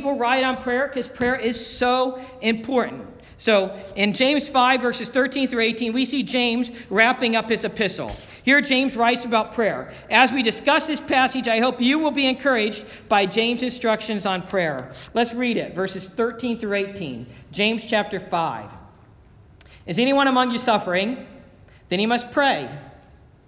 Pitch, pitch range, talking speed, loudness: 235 Hz, 205-255 Hz, 160 wpm, -21 LUFS